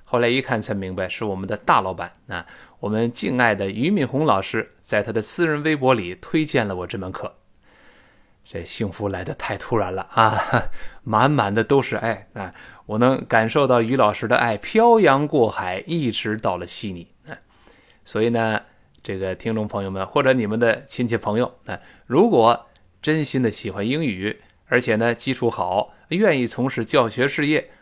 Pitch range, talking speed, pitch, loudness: 100-130 Hz, 260 characters per minute, 115 Hz, -21 LUFS